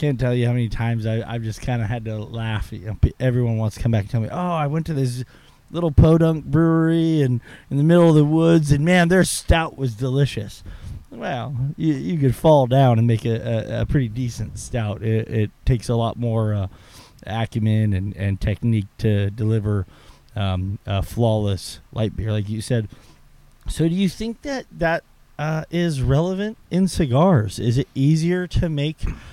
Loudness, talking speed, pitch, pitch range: -21 LUFS, 190 wpm, 120 Hz, 110-155 Hz